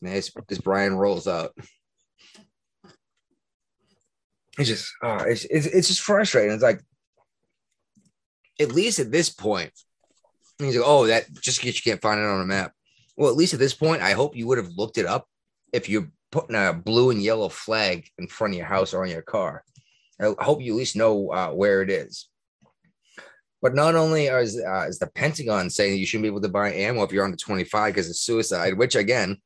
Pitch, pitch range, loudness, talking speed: 110 Hz, 100-145 Hz, -23 LUFS, 200 wpm